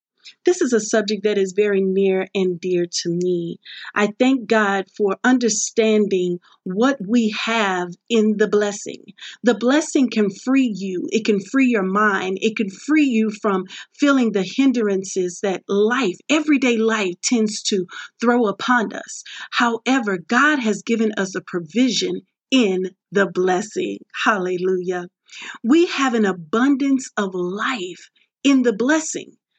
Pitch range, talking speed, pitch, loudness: 190-245 Hz, 140 wpm, 215 Hz, -19 LUFS